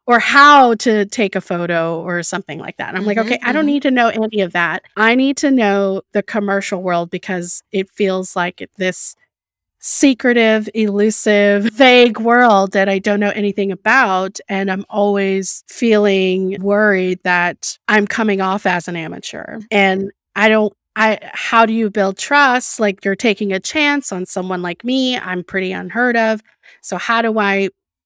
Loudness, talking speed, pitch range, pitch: -15 LUFS, 175 wpm, 190-225 Hz, 205 Hz